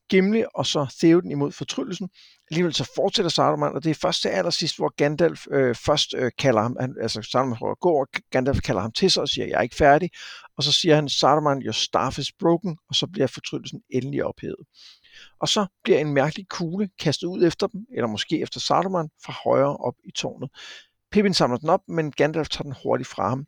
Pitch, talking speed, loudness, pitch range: 150 Hz, 210 wpm, -23 LUFS, 135-175 Hz